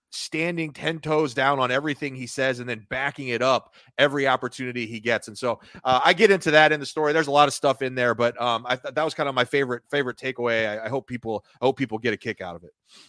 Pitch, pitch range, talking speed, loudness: 130 Hz, 120-145 Hz, 270 wpm, -23 LUFS